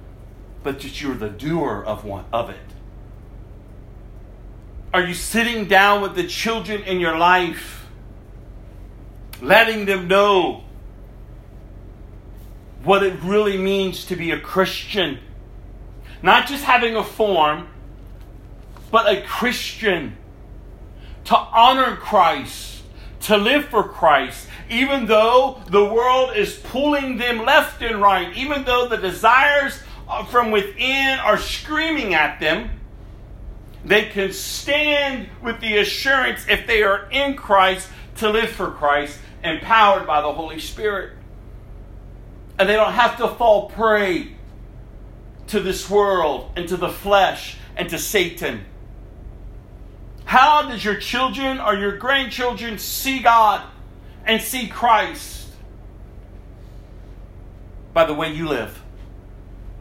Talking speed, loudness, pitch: 120 wpm, -18 LUFS, 175 Hz